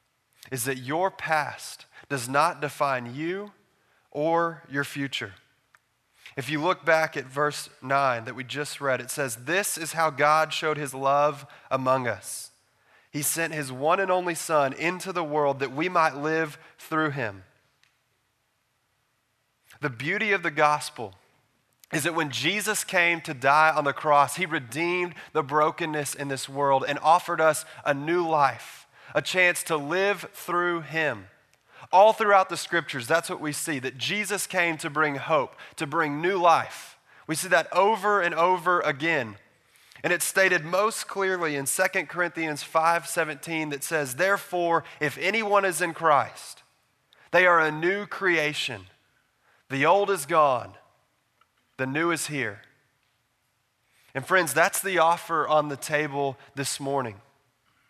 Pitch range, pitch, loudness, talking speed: 135-170 Hz, 150 Hz, -25 LUFS, 155 wpm